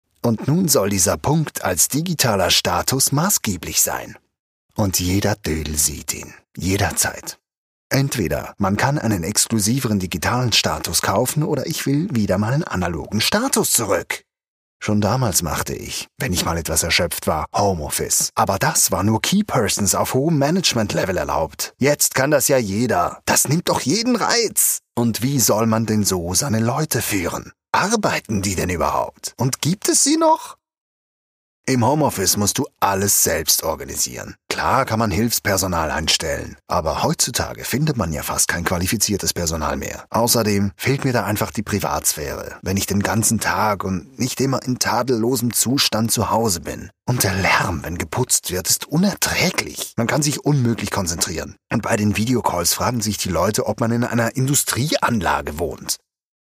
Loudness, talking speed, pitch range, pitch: -19 LUFS, 160 wpm, 95-125 Hz, 110 Hz